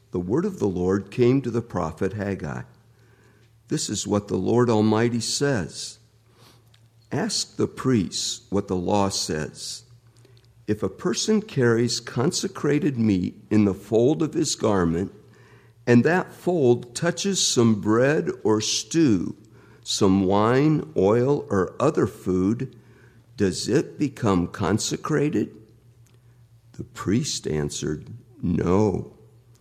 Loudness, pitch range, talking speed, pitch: -23 LUFS, 100-120 Hz, 120 wpm, 115 Hz